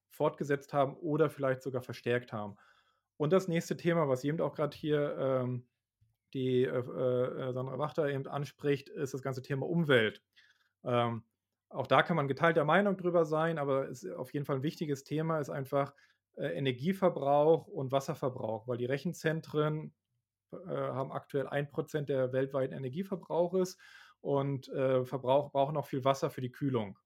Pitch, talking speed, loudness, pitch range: 140 Hz, 160 wpm, -33 LUFS, 130-155 Hz